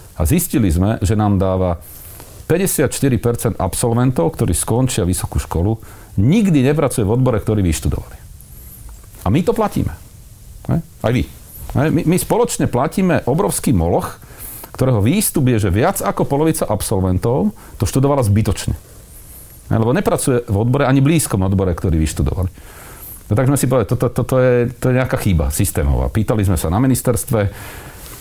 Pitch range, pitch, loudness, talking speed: 95-130 Hz, 115 Hz, -17 LUFS, 145 wpm